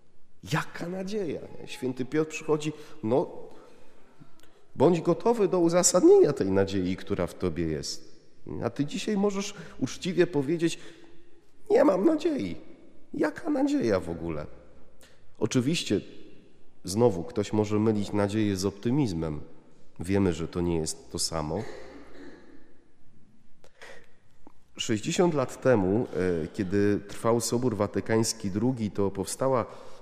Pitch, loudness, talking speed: 120 Hz, -27 LUFS, 110 wpm